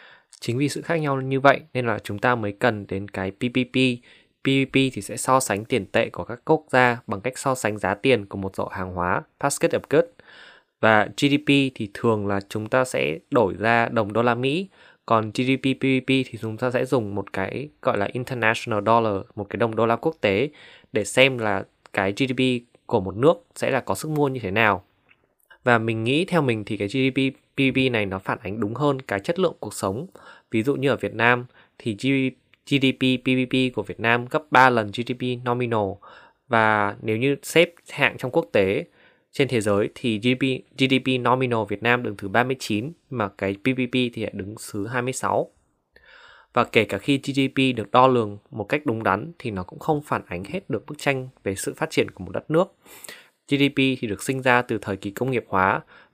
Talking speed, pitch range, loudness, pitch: 210 wpm, 105-135 Hz, -23 LUFS, 125 Hz